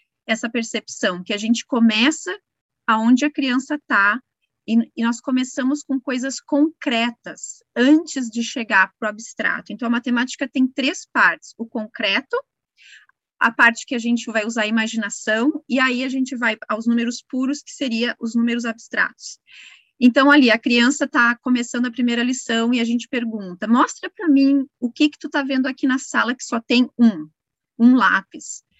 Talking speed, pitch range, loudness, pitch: 175 wpm, 230-275 Hz, -19 LUFS, 245 Hz